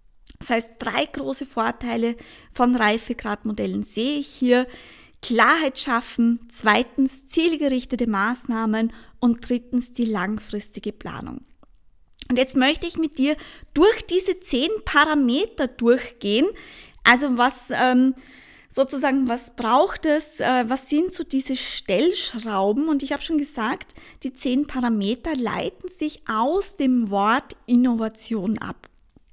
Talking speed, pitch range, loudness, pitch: 115 wpm, 230-290 Hz, -21 LUFS, 255 Hz